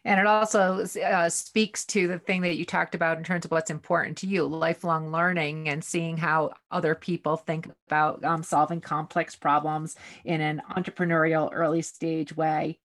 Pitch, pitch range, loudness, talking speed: 165 Hz, 155-180 Hz, -26 LUFS, 175 wpm